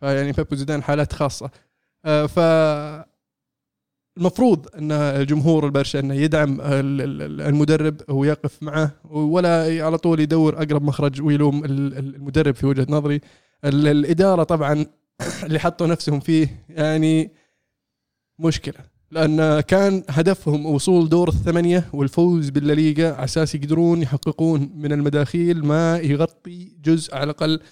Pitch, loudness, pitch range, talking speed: 150 Hz, -20 LUFS, 145-165 Hz, 115 wpm